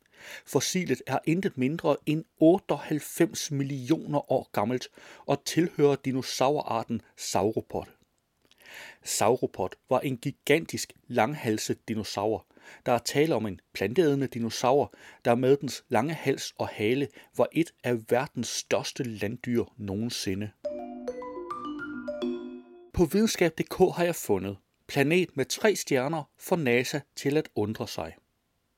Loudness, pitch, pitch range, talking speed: -28 LUFS, 130 Hz, 115-160 Hz, 115 wpm